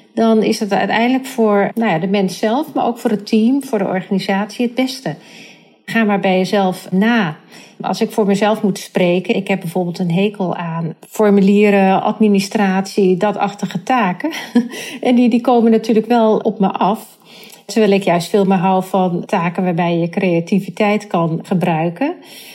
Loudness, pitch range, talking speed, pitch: -16 LUFS, 190-225 Hz, 170 wpm, 205 Hz